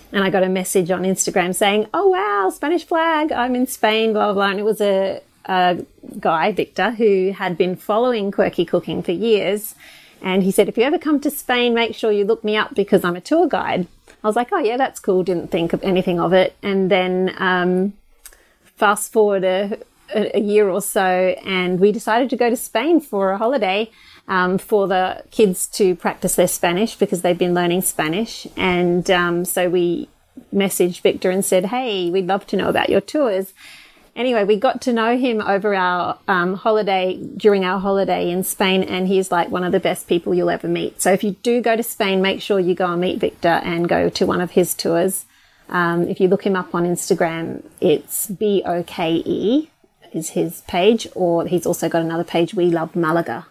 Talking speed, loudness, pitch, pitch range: 210 wpm, -18 LUFS, 195 Hz, 180-220 Hz